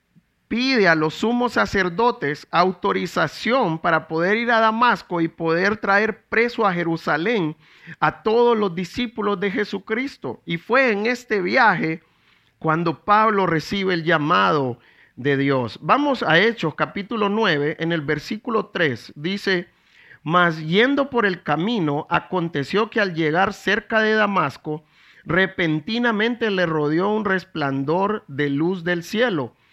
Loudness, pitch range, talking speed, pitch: -20 LUFS, 160-220 Hz, 135 wpm, 185 Hz